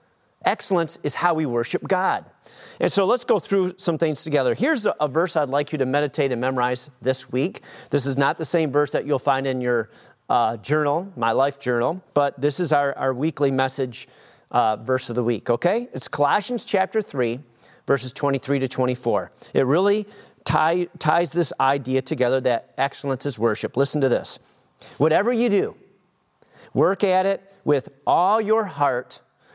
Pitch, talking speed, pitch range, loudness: 145 Hz, 175 wpm, 130-170 Hz, -22 LUFS